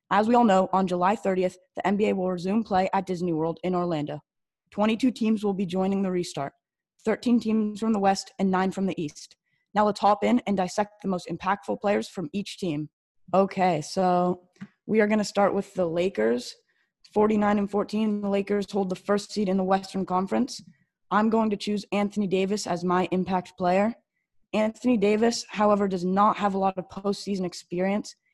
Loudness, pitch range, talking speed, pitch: -26 LUFS, 185-210 Hz, 195 wpm, 195 Hz